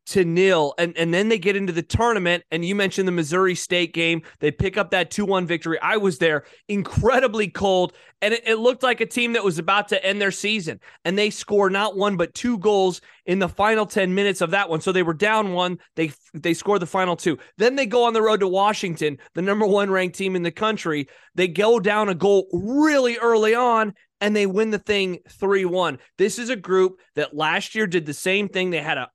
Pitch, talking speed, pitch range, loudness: 195 Hz, 235 wpm, 175-210 Hz, -21 LUFS